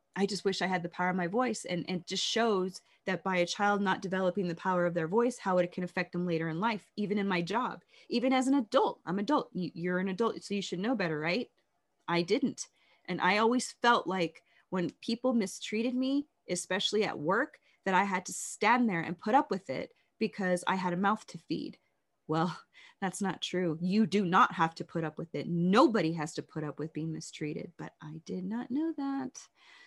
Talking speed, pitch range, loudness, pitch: 225 wpm, 175-225 Hz, -32 LUFS, 185 Hz